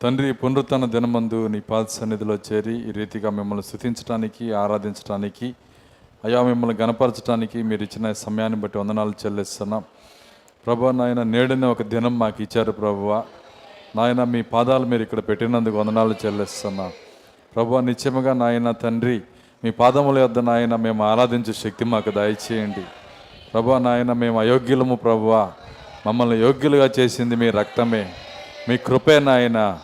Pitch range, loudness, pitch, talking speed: 105-120 Hz, -21 LUFS, 115 Hz, 125 wpm